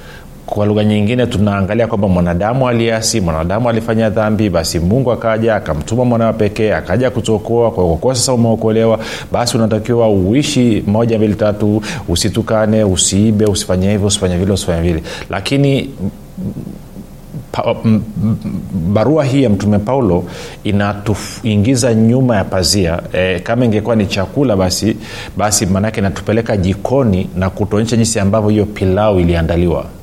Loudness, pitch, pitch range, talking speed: -14 LUFS, 105 Hz, 95-115 Hz, 130 wpm